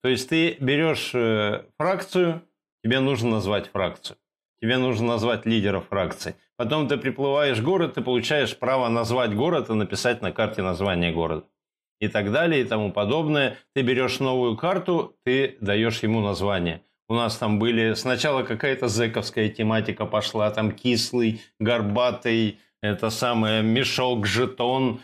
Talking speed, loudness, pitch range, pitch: 145 wpm, -24 LUFS, 105-130 Hz, 115 Hz